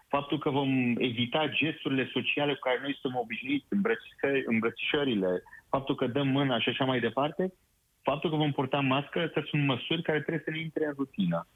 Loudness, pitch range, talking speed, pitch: -30 LUFS, 130-155 Hz, 185 wpm, 140 Hz